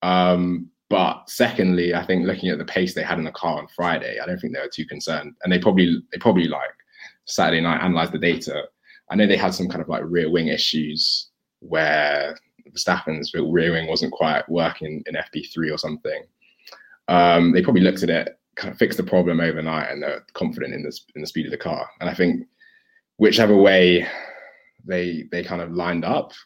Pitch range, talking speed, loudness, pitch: 80-90 Hz, 210 wpm, -21 LUFS, 90 Hz